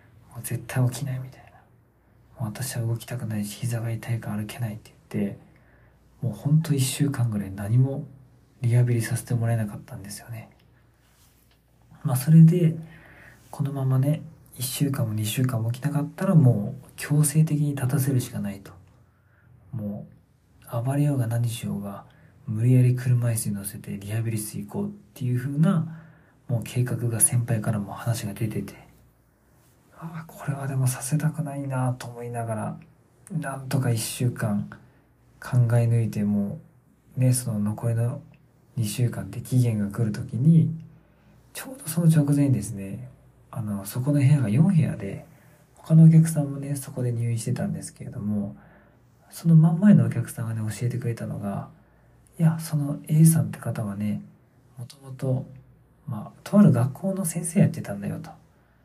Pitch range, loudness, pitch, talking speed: 115-145 Hz, -24 LUFS, 125 Hz, 310 characters per minute